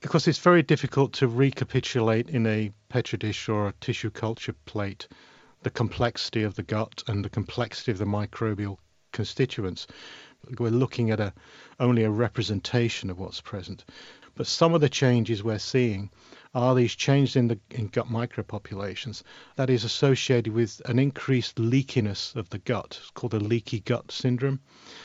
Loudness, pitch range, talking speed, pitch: -26 LUFS, 105-130 Hz, 165 wpm, 115 Hz